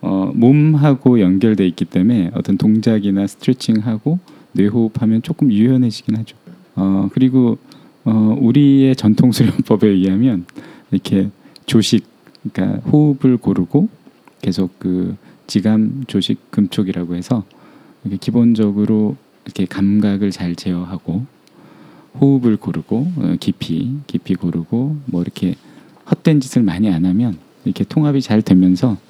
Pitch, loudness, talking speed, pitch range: 110 Hz, -16 LUFS, 285 characters per minute, 95-130 Hz